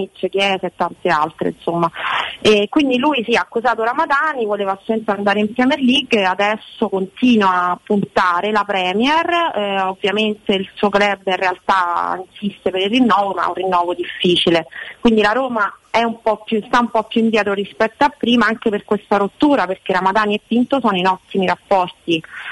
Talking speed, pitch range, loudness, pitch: 180 wpm, 185-230 Hz, -17 LUFS, 205 Hz